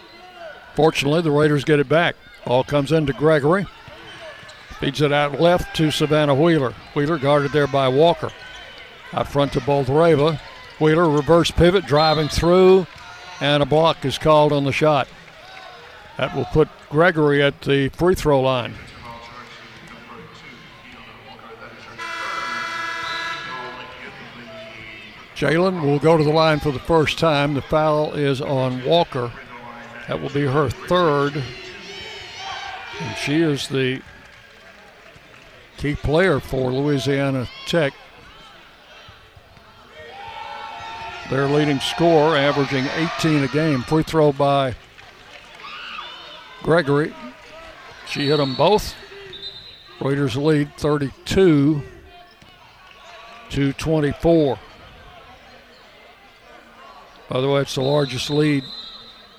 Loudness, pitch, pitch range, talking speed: -19 LUFS, 145 Hz, 135-155 Hz, 105 wpm